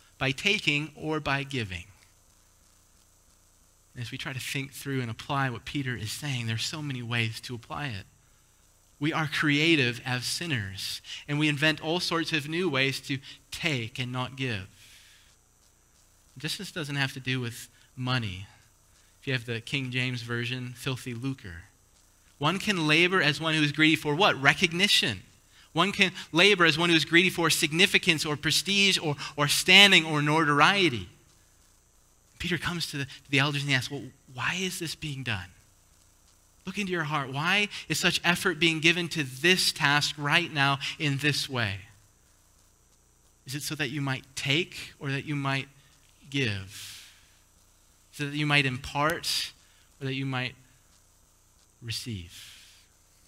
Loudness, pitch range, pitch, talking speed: -26 LUFS, 105-155 Hz, 135 Hz, 160 wpm